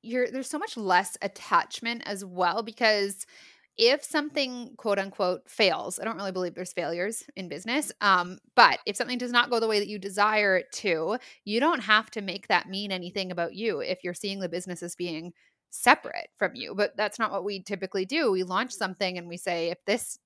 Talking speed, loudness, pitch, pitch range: 210 wpm, -27 LUFS, 200 Hz, 185-230 Hz